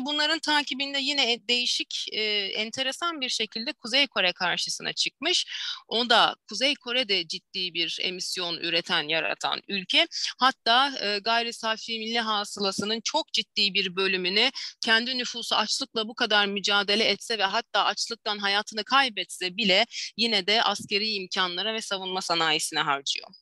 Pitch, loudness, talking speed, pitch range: 215 Hz, -25 LUFS, 135 wpm, 190-245 Hz